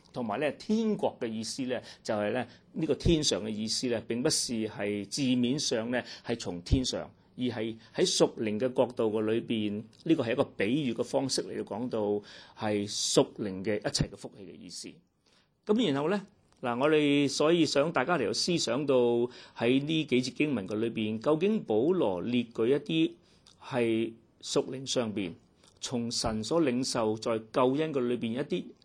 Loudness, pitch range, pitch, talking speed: -30 LUFS, 110-150 Hz, 120 Hz, 260 characters per minute